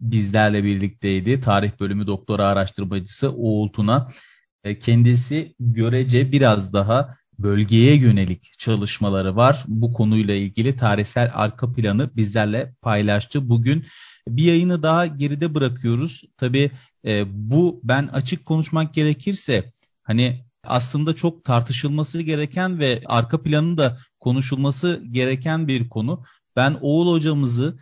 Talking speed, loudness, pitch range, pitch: 110 wpm, -20 LUFS, 110-145 Hz, 125 Hz